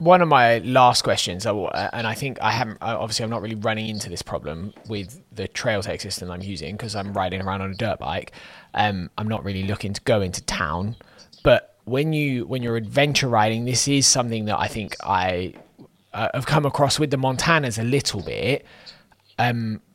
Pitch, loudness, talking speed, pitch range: 110 Hz, -22 LUFS, 200 wpm, 100-130 Hz